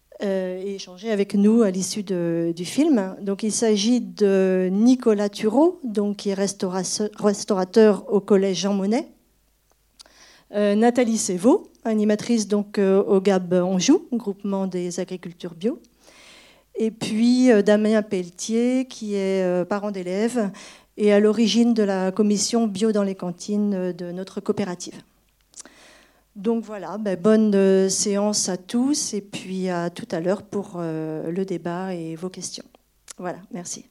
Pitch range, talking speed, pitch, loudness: 190-220 Hz, 135 wpm, 205 Hz, -22 LUFS